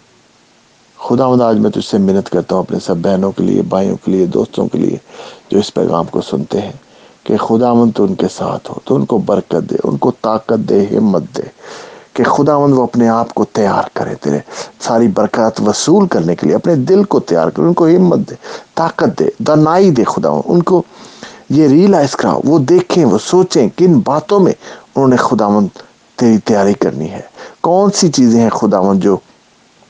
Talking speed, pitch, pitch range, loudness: 200 wpm, 125 Hz, 105-175 Hz, -12 LUFS